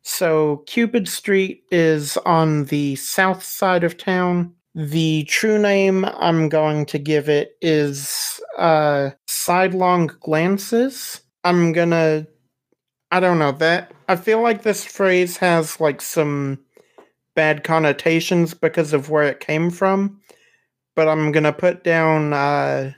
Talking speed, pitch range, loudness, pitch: 130 wpm, 150-185 Hz, -18 LUFS, 165 Hz